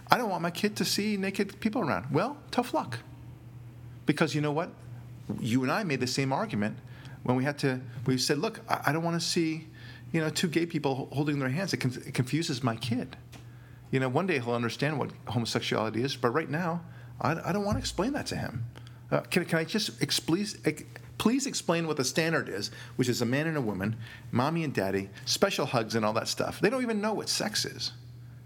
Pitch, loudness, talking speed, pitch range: 130 Hz, -30 LUFS, 215 wpm, 120-165 Hz